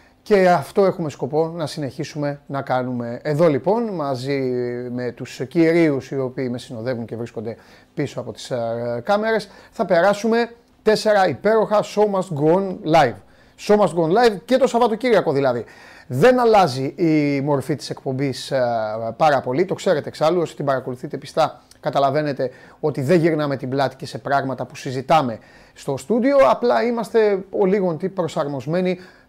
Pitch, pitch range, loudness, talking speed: 155 Hz, 135-195 Hz, -20 LUFS, 150 wpm